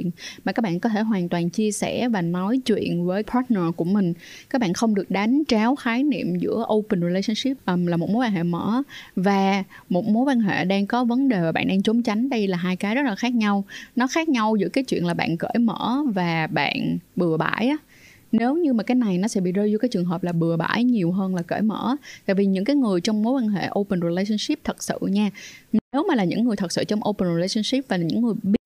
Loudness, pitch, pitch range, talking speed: -23 LUFS, 210 Hz, 185-240 Hz, 250 wpm